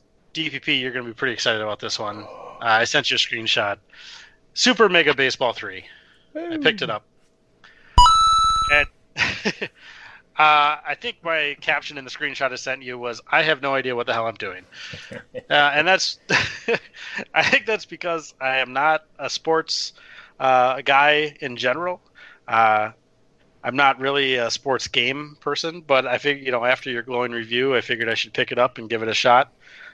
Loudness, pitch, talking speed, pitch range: -20 LUFS, 140 Hz, 180 wpm, 125-160 Hz